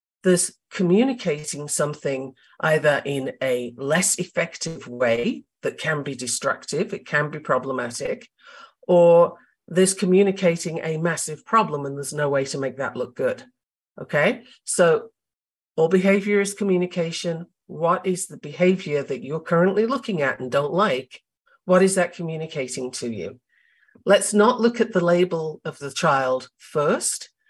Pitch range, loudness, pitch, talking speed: 150-200 Hz, -22 LUFS, 170 Hz, 145 wpm